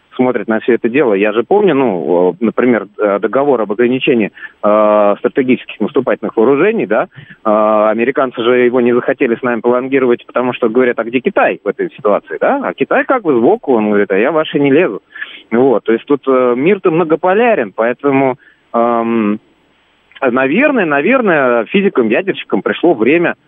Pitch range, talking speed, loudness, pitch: 110-130 Hz, 160 wpm, -12 LUFS, 120 Hz